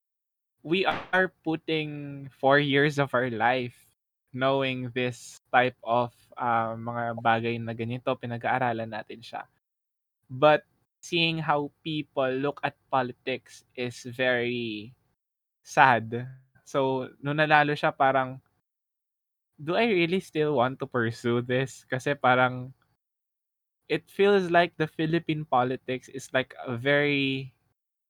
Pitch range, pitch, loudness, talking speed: 120-145 Hz, 130 Hz, -27 LUFS, 115 wpm